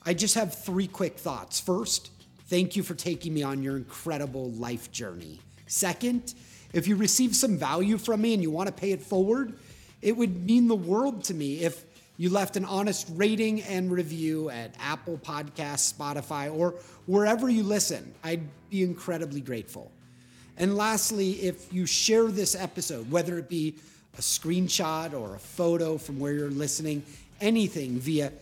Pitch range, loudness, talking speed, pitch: 150-200 Hz, -28 LUFS, 170 wpm, 175 Hz